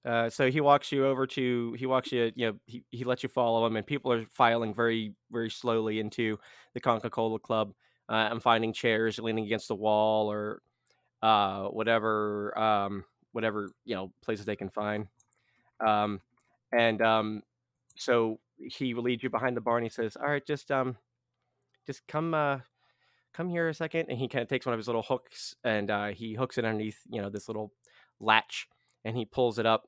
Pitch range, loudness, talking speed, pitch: 110-125 Hz, -30 LUFS, 200 wpm, 115 Hz